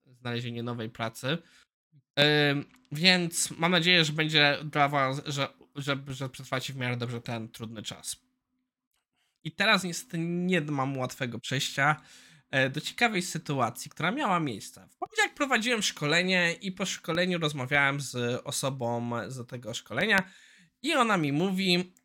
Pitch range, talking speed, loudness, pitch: 130-180 Hz, 140 wpm, -28 LUFS, 150 Hz